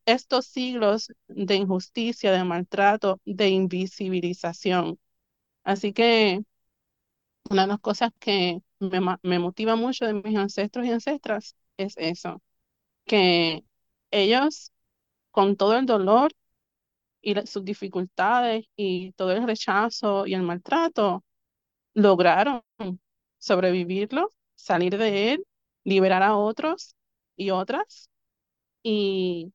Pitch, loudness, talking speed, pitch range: 200 Hz, -24 LUFS, 110 wpm, 185-225 Hz